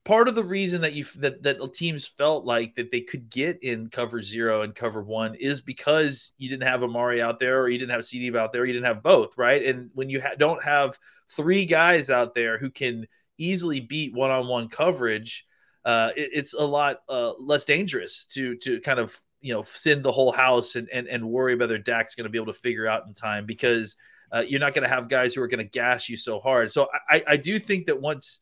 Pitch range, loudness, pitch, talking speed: 120-150 Hz, -24 LUFS, 130 Hz, 250 wpm